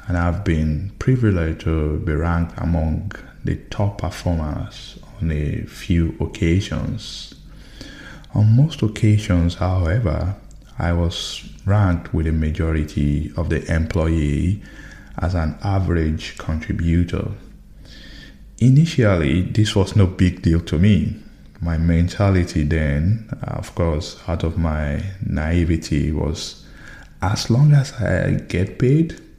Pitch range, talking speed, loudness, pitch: 80-100 Hz, 115 wpm, -20 LUFS, 85 Hz